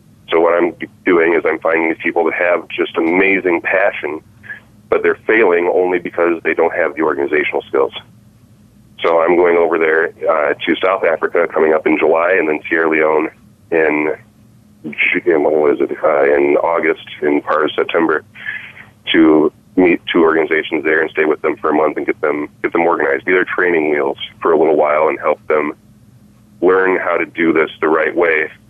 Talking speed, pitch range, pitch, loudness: 185 wpm, 80-115 Hz, 90 Hz, -14 LUFS